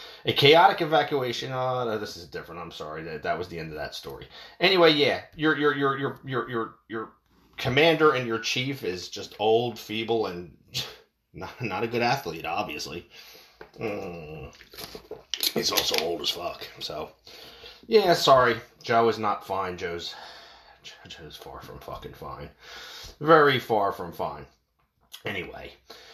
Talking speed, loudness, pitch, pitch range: 150 wpm, -25 LUFS, 115 Hz, 110-135 Hz